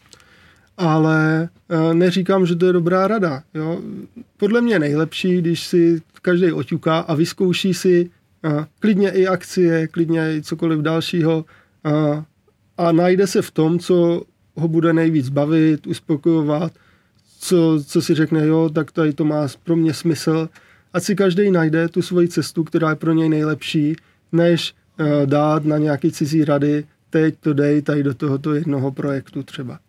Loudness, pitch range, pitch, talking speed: -18 LUFS, 150-175 Hz, 160 Hz, 160 wpm